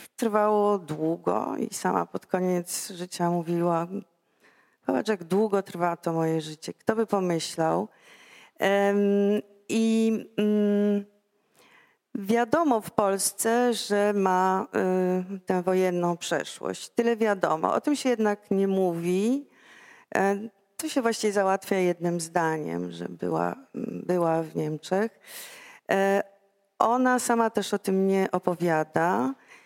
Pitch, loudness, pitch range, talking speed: 195 Hz, -26 LUFS, 175-215 Hz, 115 wpm